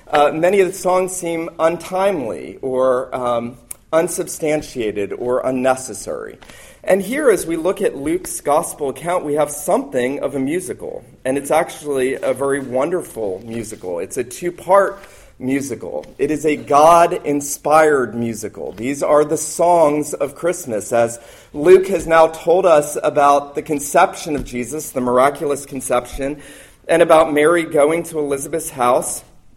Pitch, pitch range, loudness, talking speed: 150 Hz, 130-175 Hz, -17 LUFS, 145 wpm